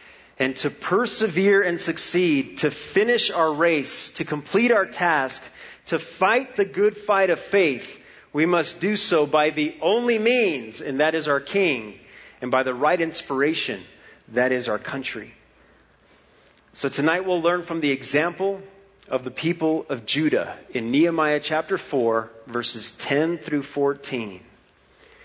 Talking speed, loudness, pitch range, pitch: 145 wpm, -22 LUFS, 140-195 Hz, 160 Hz